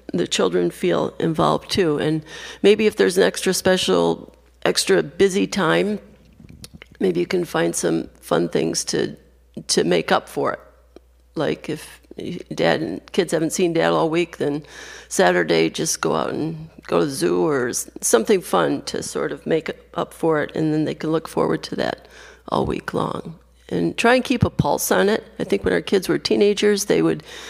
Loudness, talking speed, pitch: -20 LUFS, 190 wpm, 160 Hz